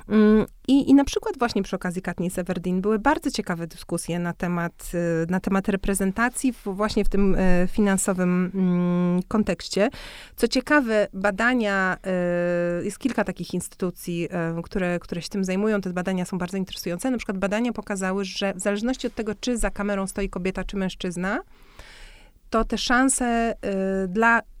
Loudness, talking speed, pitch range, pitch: -24 LUFS, 150 wpm, 180-220 Hz, 195 Hz